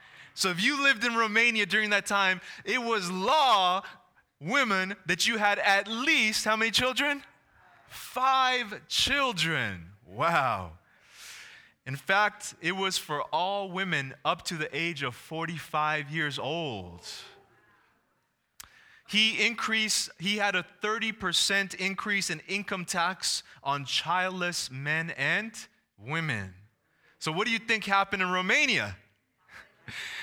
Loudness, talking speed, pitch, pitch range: -27 LUFS, 125 wpm, 195 Hz, 165-215 Hz